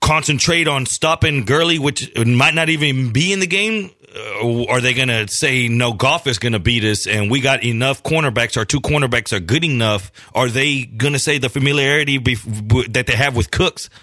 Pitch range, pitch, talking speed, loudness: 120-145 Hz, 130 Hz, 220 wpm, -16 LUFS